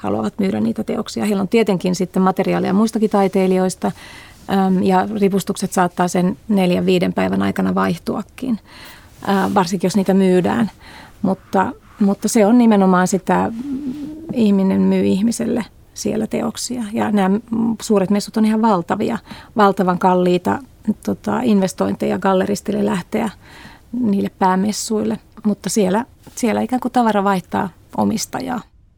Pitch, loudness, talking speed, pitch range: 200 Hz, -18 LUFS, 120 wpm, 185-220 Hz